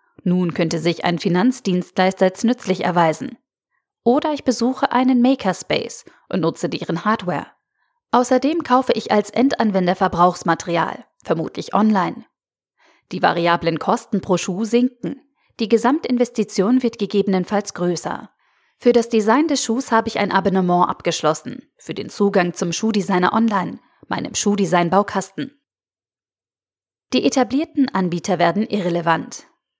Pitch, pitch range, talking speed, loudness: 205 Hz, 180-245 Hz, 120 wpm, -19 LUFS